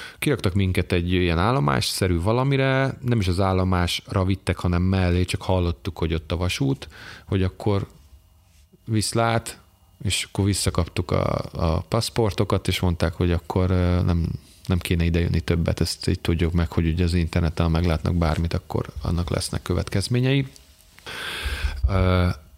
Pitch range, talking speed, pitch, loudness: 85-100 Hz, 140 wpm, 90 Hz, -23 LUFS